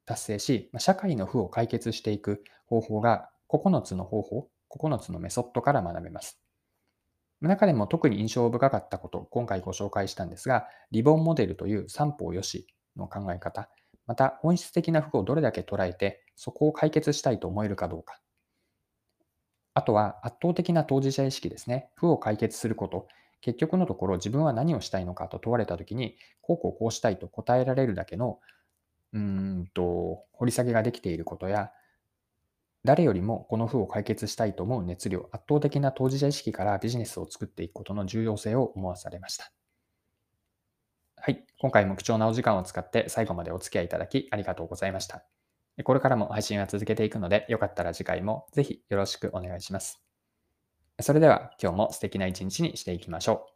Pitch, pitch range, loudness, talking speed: 110 Hz, 95-130 Hz, -28 LUFS, 375 characters per minute